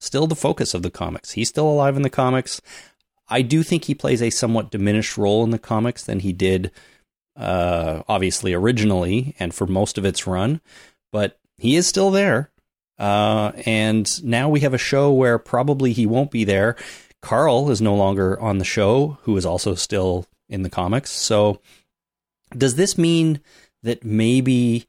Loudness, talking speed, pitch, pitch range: -20 LUFS, 180 wpm, 115 Hz, 100-135 Hz